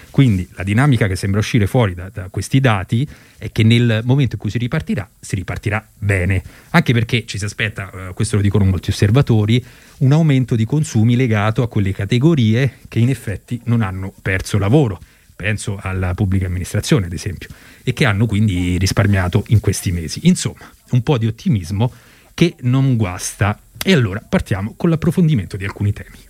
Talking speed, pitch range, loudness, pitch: 180 wpm, 100-125 Hz, -17 LUFS, 110 Hz